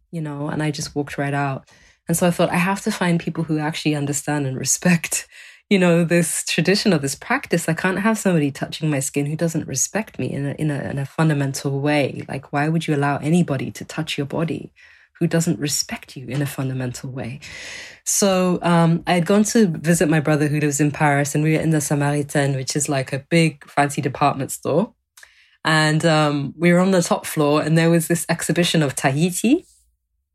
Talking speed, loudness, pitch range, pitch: 215 wpm, -20 LUFS, 145-175 Hz, 155 Hz